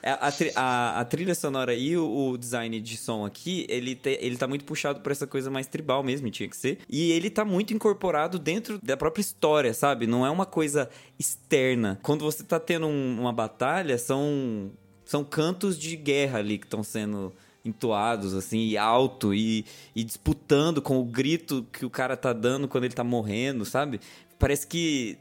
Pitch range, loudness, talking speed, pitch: 115-155 Hz, -27 LUFS, 190 wpm, 135 Hz